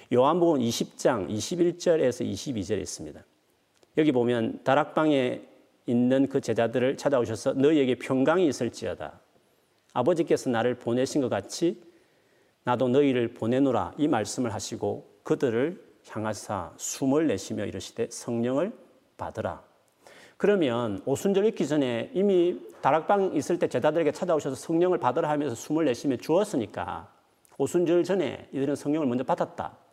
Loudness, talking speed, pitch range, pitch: -27 LUFS, 320 characters per minute, 120-170 Hz, 135 Hz